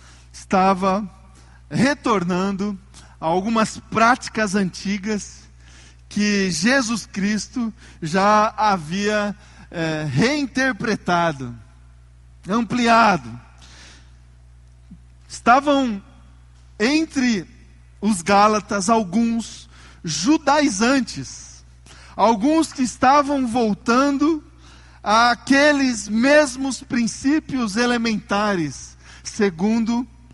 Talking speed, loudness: 55 wpm, -19 LUFS